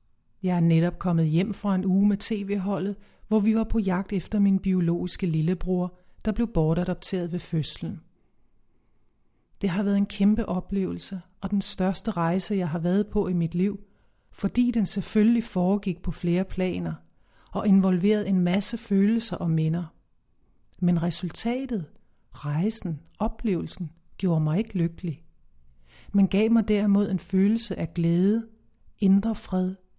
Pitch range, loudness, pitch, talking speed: 170-205 Hz, -26 LUFS, 185 Hz, 145 wpm